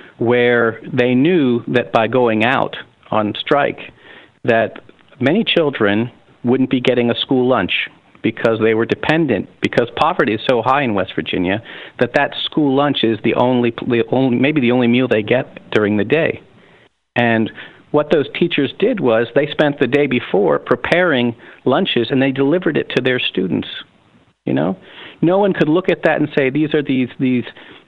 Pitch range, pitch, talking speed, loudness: 115-140 Hz, 125 Hz, 175 wpm, -16 LUFS